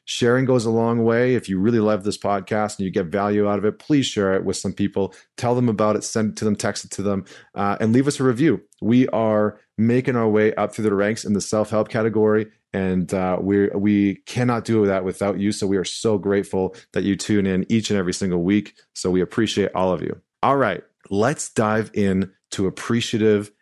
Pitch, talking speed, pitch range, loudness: 105 Hz, 230 wpm, 100-110 Hz, -21 LUFS